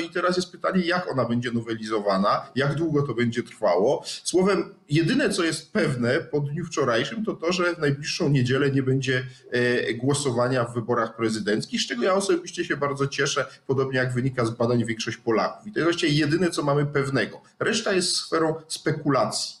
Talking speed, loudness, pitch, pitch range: 185 wpm, -24 LUFS, 140 Hz, 125-170 Hz